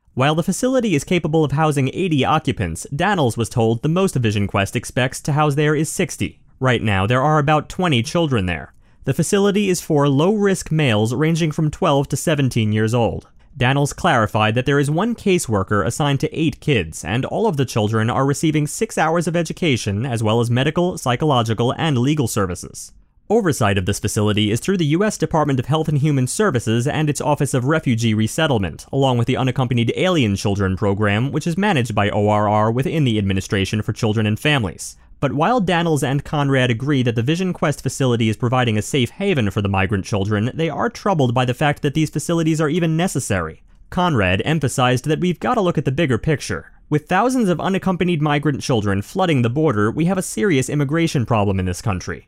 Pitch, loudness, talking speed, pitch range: 140 Hz, -19 LUFS, 200 wpm, 110-160 Hz